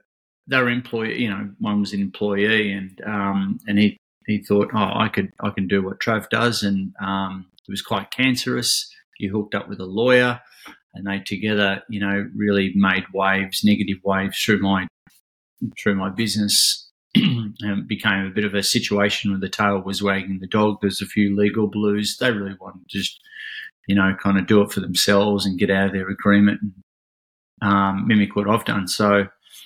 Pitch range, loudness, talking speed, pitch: 95-105 Hz, -21 LUFS, 195 wpm, 100 Hz